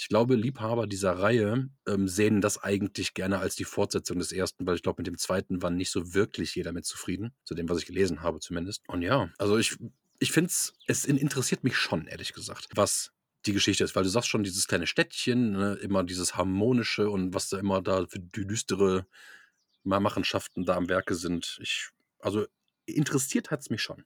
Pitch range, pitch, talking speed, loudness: 95-120 Hz, 100 Hz, 205 wpm, -29 LUFS